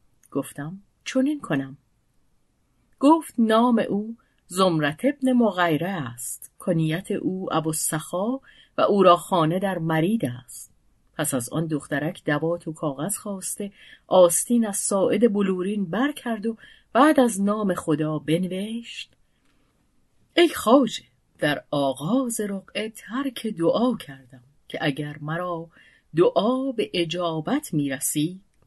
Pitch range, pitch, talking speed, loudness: 155-225 Hz, 180 Hz, 120 wpm, -23 LUFS